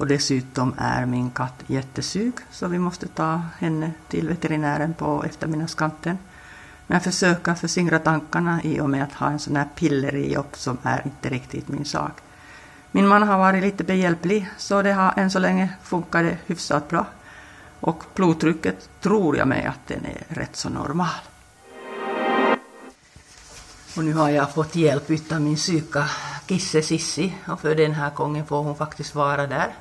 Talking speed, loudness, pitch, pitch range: 165 wpm, -23 LUFS, 155 Hz, 145-175 Hz